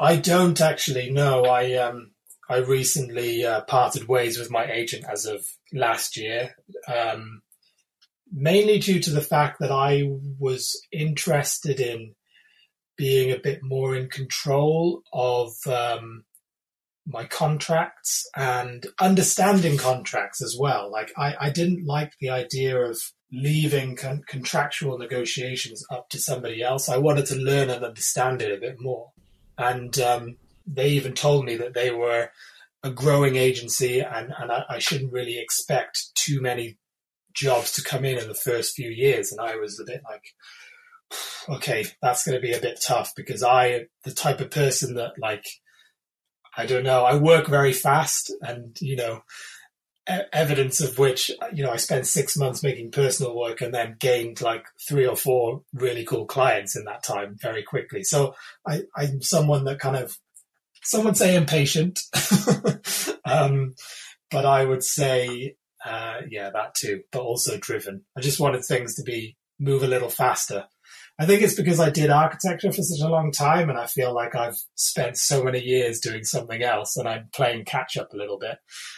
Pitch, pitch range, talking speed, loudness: 135 Hz, 125-150 Hz, 170 wpm, -23 LUFS